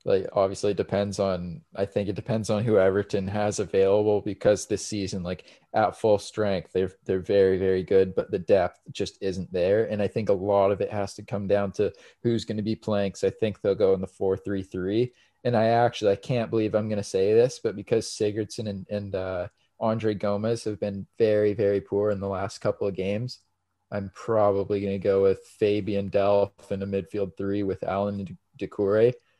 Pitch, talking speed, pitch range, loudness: 100 Hz, 215 wpm, 95-110 Hz, -26 LUFS